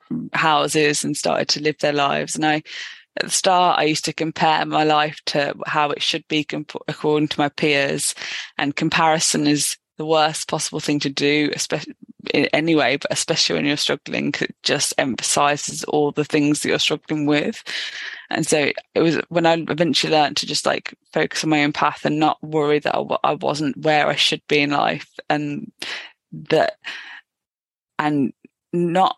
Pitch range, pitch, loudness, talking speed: 145-160 Hz, 150 Hz, -20 LUFS, 180 wpm